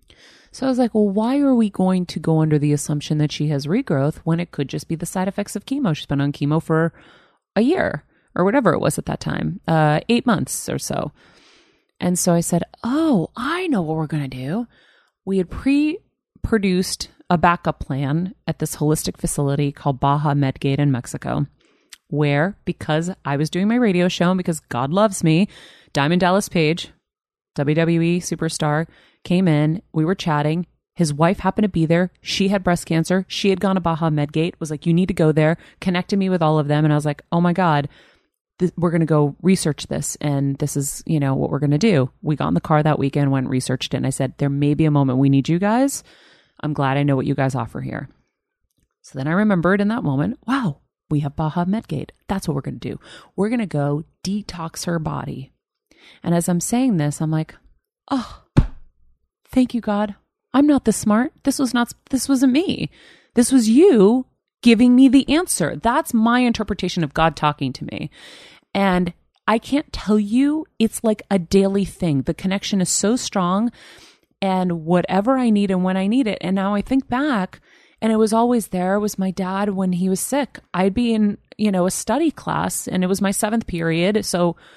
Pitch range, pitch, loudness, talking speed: 155-215 Hz, 180 Hz, -20 LUFS, 215 wpm